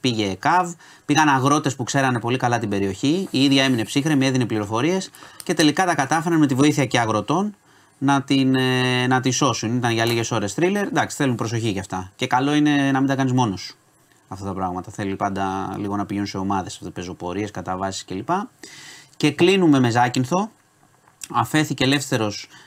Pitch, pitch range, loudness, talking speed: 130 Hz, 105-145 Hz, -21 LUFS, 180 wpm